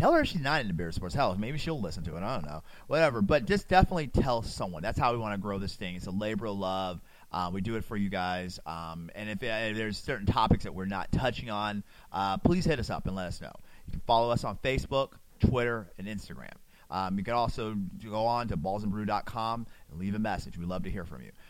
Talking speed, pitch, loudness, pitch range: 255 wpm, 105 Hz, -31 LUFS, 95-115 Hz